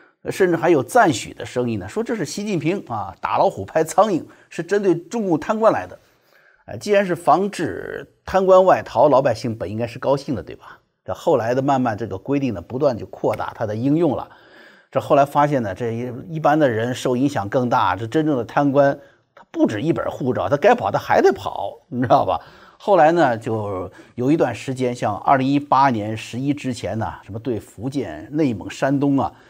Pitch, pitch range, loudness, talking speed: 140 Hz, 125-180 Hz, -20 LUFS, 295 characters per minute